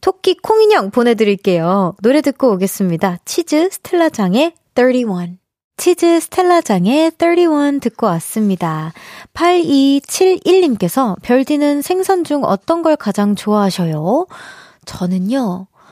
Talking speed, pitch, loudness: 235 characters per minute, 265 Hz, -14 LUFS